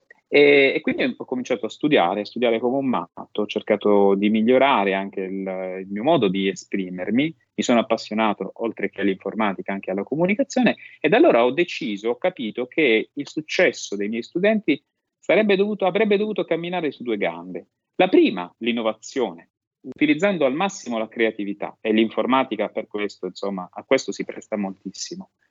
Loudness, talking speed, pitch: -22 LUFS, 160 wpm, 115 Hz